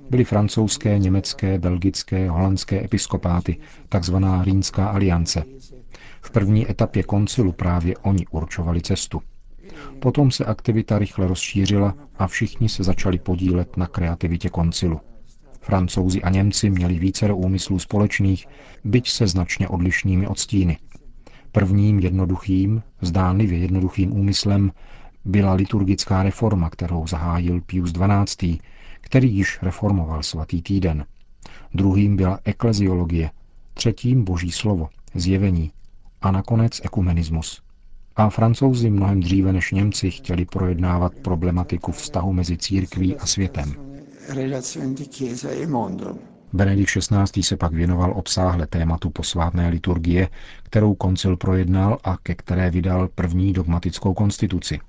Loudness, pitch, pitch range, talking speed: -21 LUFS, 95 Hz, 90-105 Hz, 115 wpm